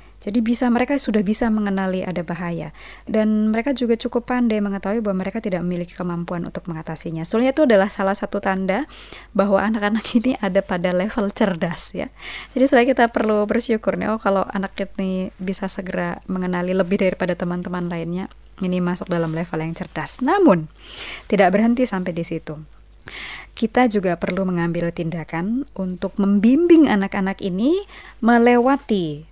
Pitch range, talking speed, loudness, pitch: 180-225 Hz, 150 wpm, -20 LUFS, 195 Hz